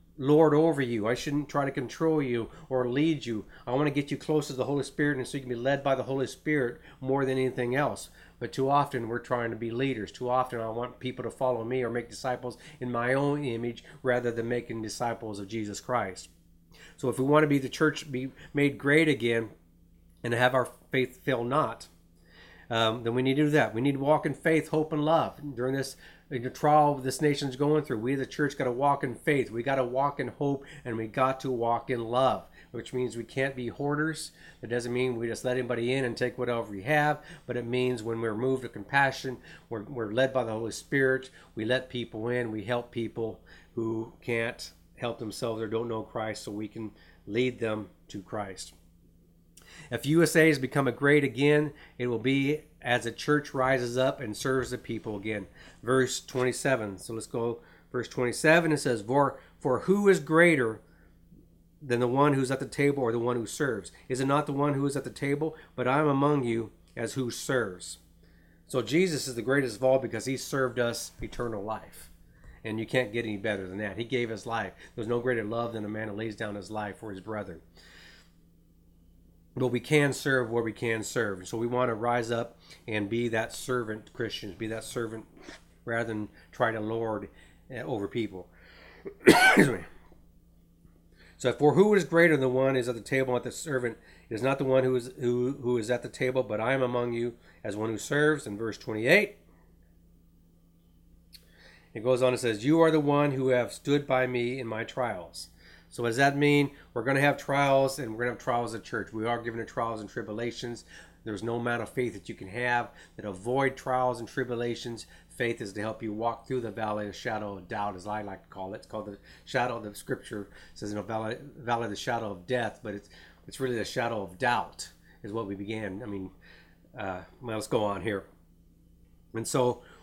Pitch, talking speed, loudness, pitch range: 120 Hz, 220 wpm, -29 LUFS, 110-135 Hz